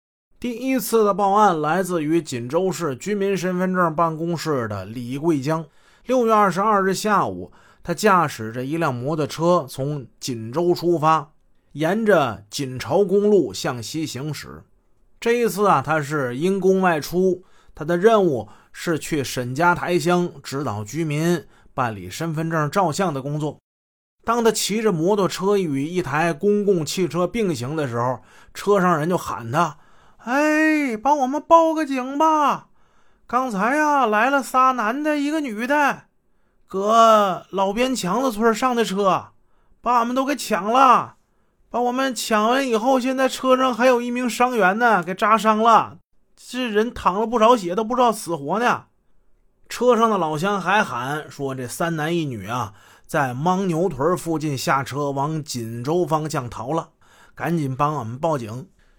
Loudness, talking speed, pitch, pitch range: -20 LUFS, 225 characters per minute, 180 Hz, 150-225 Hz